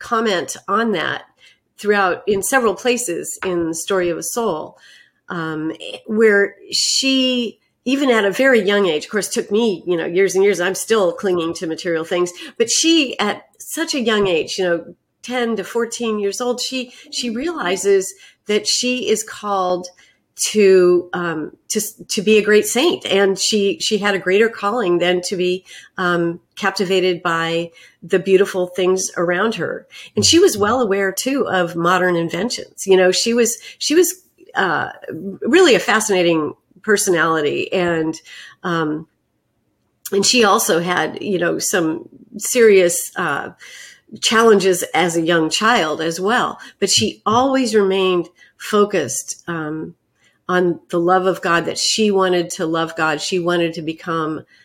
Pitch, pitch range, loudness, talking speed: 195 Hz, 175-235 Hz, -17 LUFS, 155 wpm